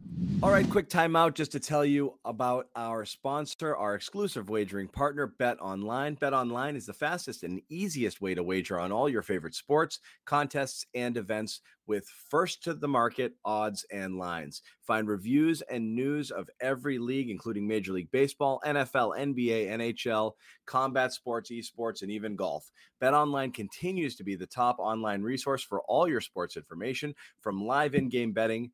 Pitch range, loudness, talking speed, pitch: 110-145 Hz, -31 LUFS, 165 wpm, 125 Hz